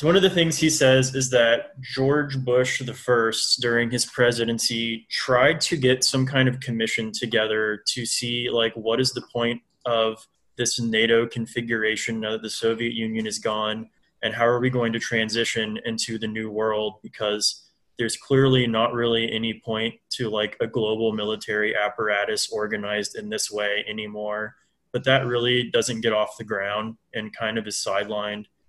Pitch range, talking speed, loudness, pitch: 110-125 Hz, 175 wpm, -23 LUFS, 115 Hz